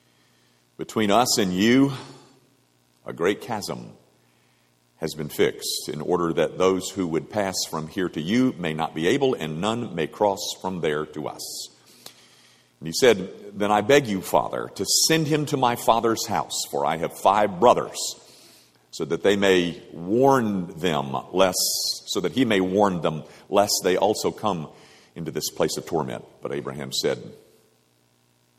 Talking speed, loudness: 165 wpm, -23 LUFS